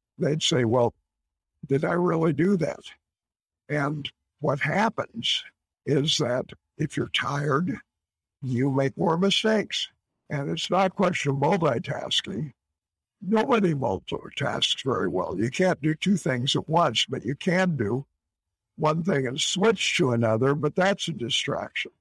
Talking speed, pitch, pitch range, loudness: 140 wpm, 145 Hz, 115-180 Hz, -25 LUFS